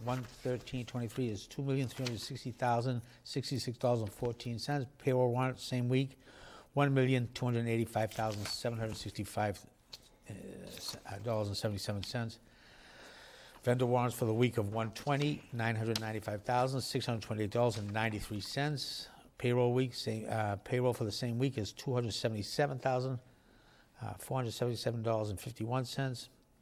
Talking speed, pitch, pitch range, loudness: 160 wpm, 120 Hz, 110-130 Hz, -36 LUFS